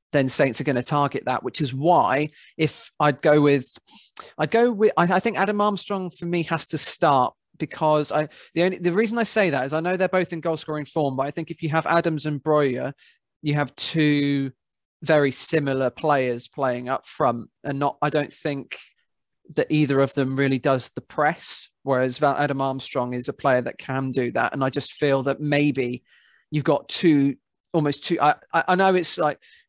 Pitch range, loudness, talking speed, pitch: 135-165 Hz, -22 LUFS, 205 wpm, 150 Hz